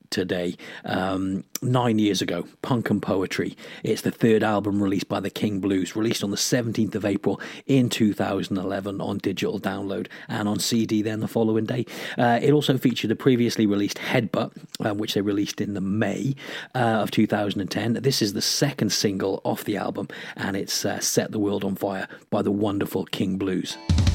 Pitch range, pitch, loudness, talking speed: 100-115 Hz, 105 Hz, -24 LUFS, 185 wpm